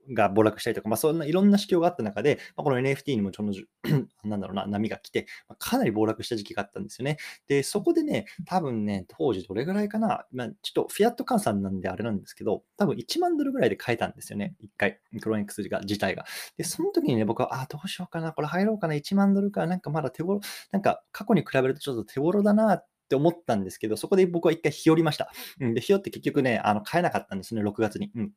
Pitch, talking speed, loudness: 155 Hz, 505 characters per minute, -27 LUFS